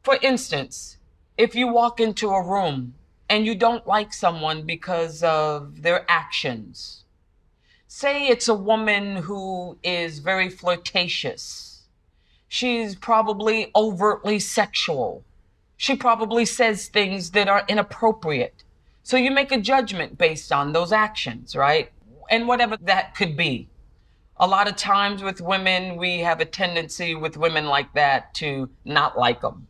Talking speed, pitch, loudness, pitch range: 140 wpm, 195 Hz, -22 LUFS, 165-220 Hz